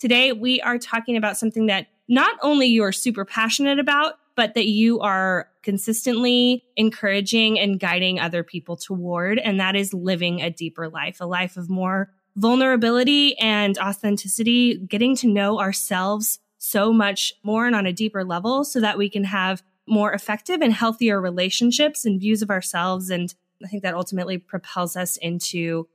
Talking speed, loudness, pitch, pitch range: 165 wpm, -21 LUFS, 205 Hz, 185-230 Hz